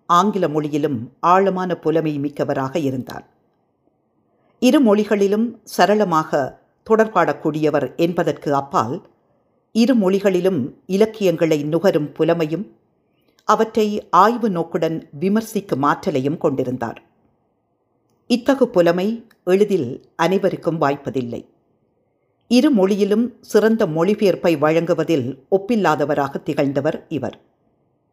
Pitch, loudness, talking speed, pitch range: 180 Hz, -19 LUFS, 75 wpm, 155-210 Hz